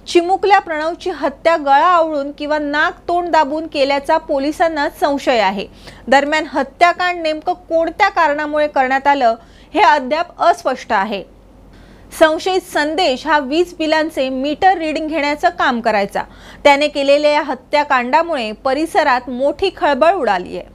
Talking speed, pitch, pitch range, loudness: 125 wpm, 310 Hz, 280-340 Hz, -15 LUFS